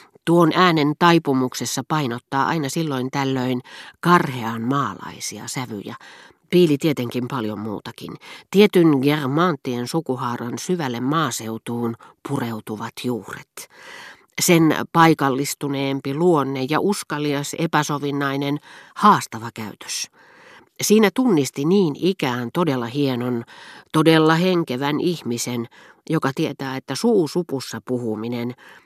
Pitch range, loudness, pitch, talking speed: 125-165 Hz, -20 LUFS, 140 Hz, 90 wpm